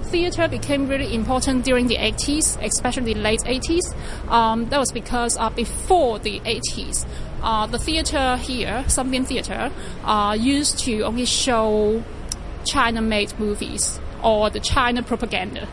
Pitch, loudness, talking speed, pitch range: 240 Hz, -21 LUFS, 140 wpm, 225-270 Hz